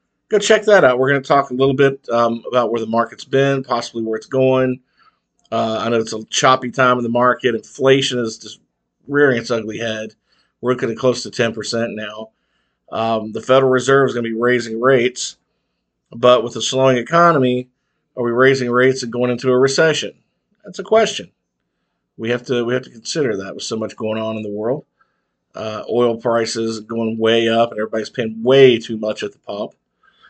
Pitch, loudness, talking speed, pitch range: 120 Hz, -17 LUFS, 210 wpm, 115-130 Hz